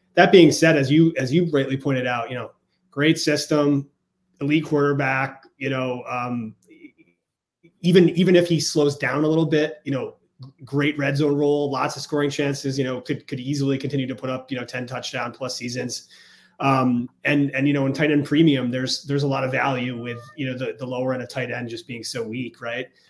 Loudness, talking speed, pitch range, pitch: -22 LUFS, 215 wpm, 130-150 Hz, 140 Hz